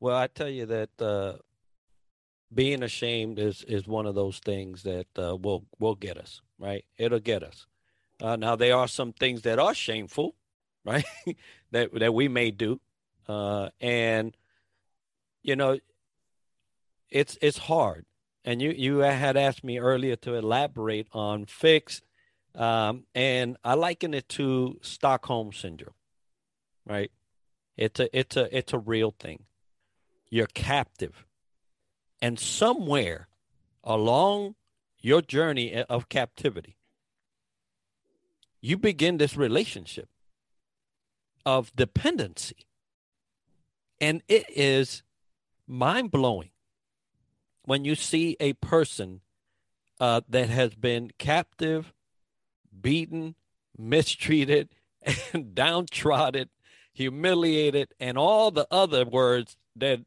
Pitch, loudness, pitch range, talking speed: 125 Hz, -27 LUFS, 110-140 Hz, 115 wpm